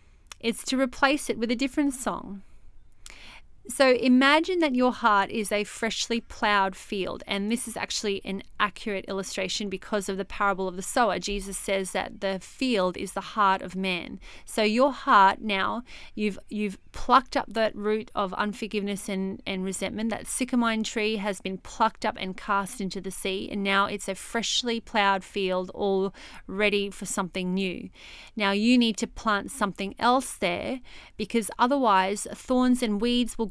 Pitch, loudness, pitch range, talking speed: 205 Hz, -26 LUFS, 195-230 Hz, 170 wpm